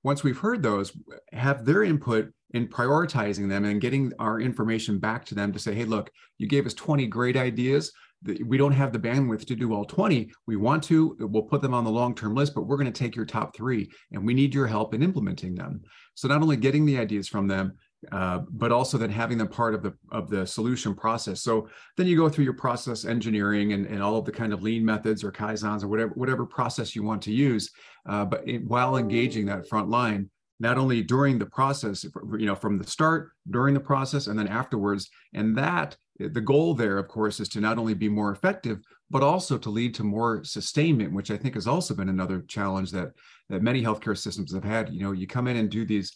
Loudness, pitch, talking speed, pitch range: -26 LUFS, 115 Hz, 230 wpm, 105-130 Hz